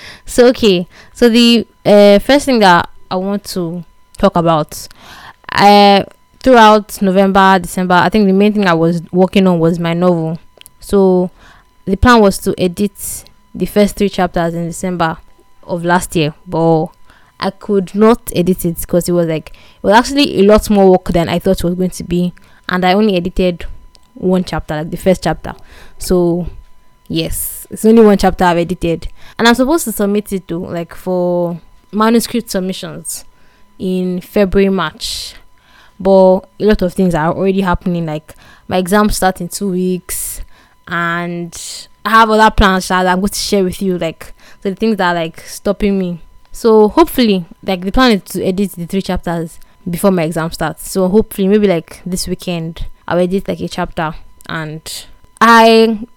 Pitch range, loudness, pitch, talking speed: 175-205 Hz, -13 LUFS, 185 Hz, 175 wpm